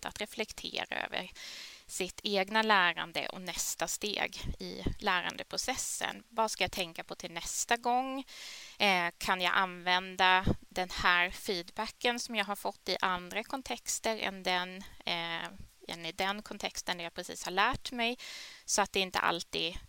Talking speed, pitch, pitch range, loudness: 150 wpm, 195 Hz, 180-225 Hz, -33 LUFS